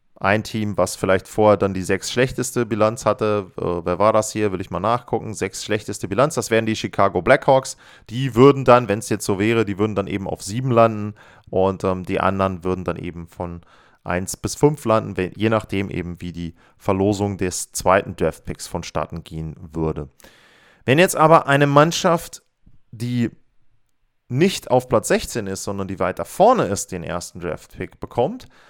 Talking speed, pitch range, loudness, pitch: 180 wpm, 90-120 Hz, -20 LUFS, 105 Hz